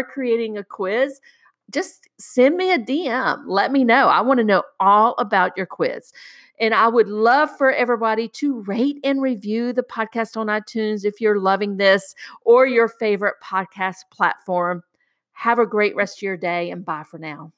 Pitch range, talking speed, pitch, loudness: 195-255 Hz, 180 wpm, 225 Hz, -19 LUFS